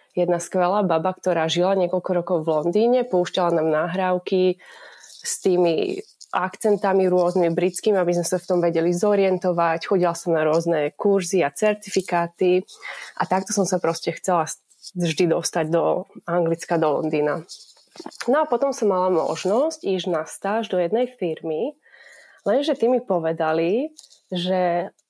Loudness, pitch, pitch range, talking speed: -22 LUFS, 180 Hz, 170-195 Hz, 140 wpm